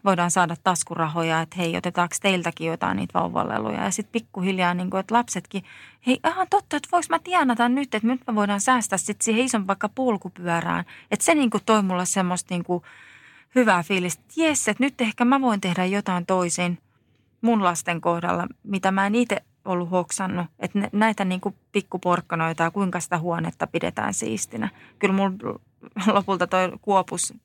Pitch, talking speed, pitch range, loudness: 195 Hz, 175 wpm, 175-225 Hz, -23 LUFS